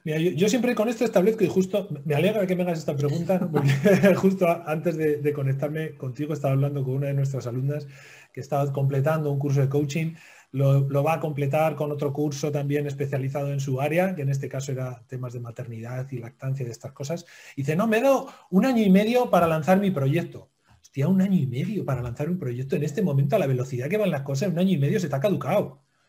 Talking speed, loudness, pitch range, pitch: 240 wpm, -24 LUFS, 140-180 Hz, 150 Hz